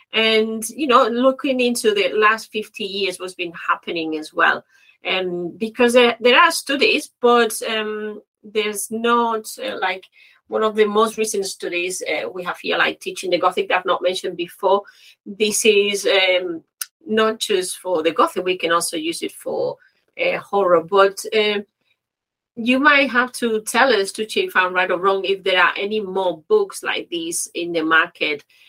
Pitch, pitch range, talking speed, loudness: 215 Hz, 185-245 Hz, 180 wpm, -19 LUFS